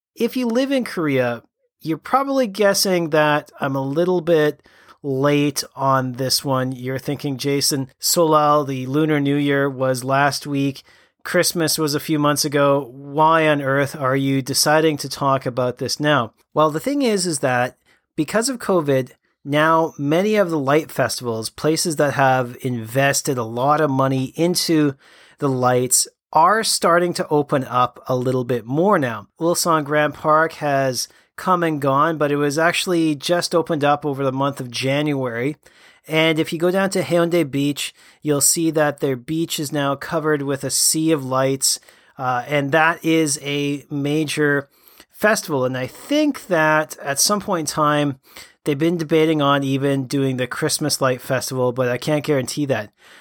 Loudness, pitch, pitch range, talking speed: -19 LUFS, 145 Hz, 135-160 Hz, 170 wpm